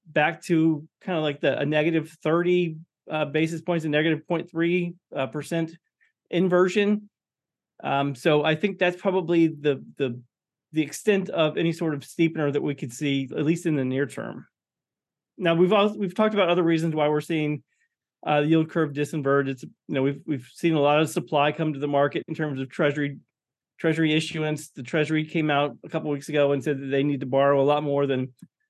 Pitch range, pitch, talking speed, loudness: 145-170 Hz, 155 Hz, 205 wpm, -24 LUFS